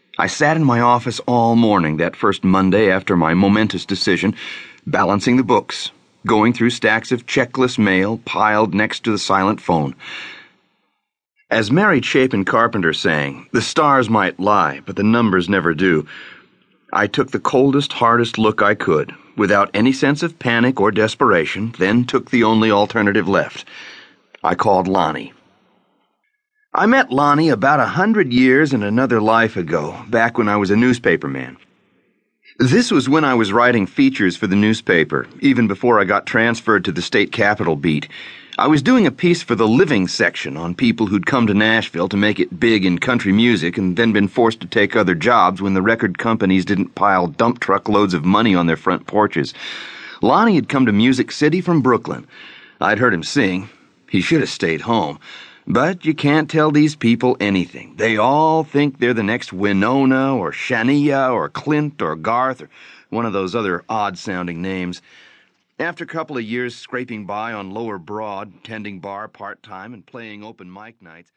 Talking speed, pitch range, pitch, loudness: 180 wpm, 100-130 Hz, 115 Hz, -16 LUFS